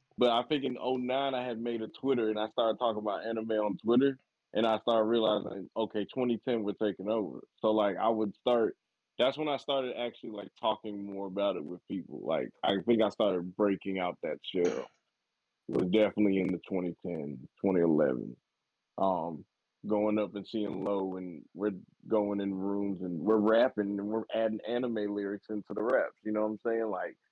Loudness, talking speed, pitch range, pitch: -32 LUFS, 190 wpm, 100-115 Hz, 110 Hz